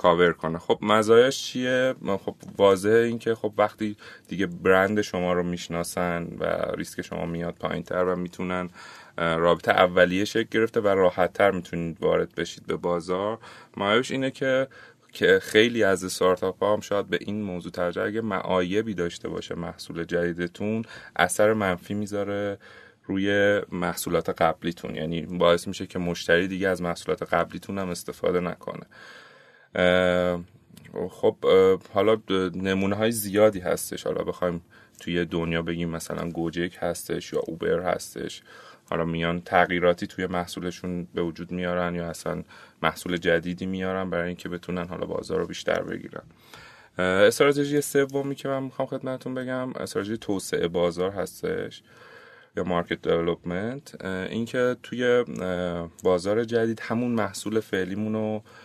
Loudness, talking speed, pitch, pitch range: -25 LUFS, 135 wpm, 95 Hz, 85-110 Hz